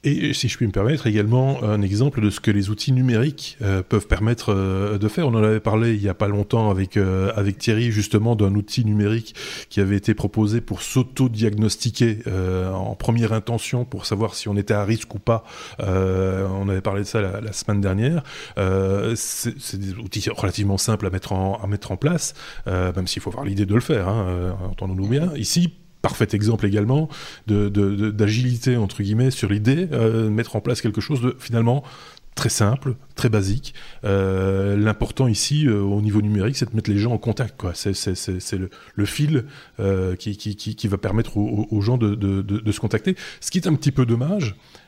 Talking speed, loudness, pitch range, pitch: 215 wpm, -22 LUFS, 100-120 Hz, 110 Hz